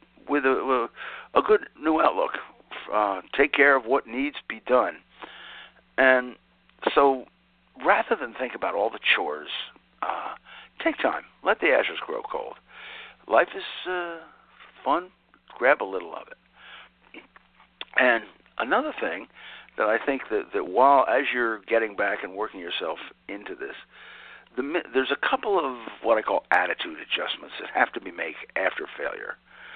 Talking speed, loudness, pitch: 155 wpm, -25 LUFS, 180 Hz